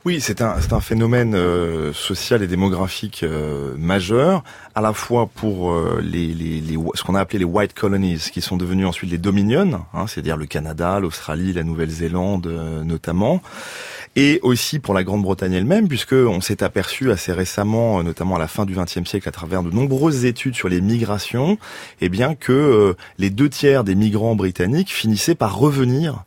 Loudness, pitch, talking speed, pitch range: -19 LUFS, 100 Hz, 190 wpm, 90-120 Hz